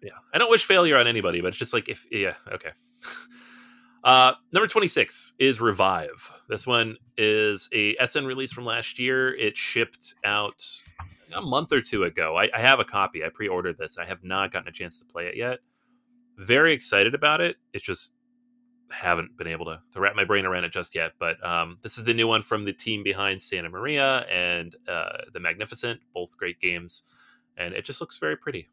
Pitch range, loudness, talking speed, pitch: 95-130 Hz, -24 LUFS, 205 wpm, 115 Hz